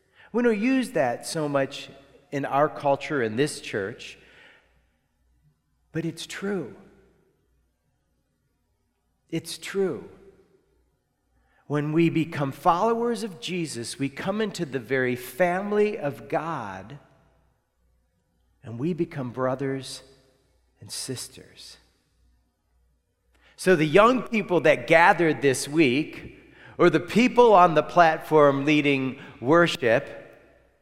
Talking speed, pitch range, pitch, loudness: 105 wpm, 130-180 Hz, 150 Hz, -23 LUFS